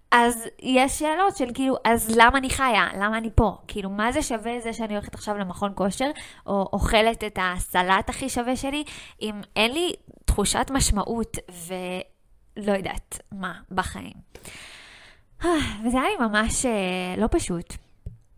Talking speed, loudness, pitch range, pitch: 145 wpm, -24 LUFS, 195-255 Hz, 220 Hz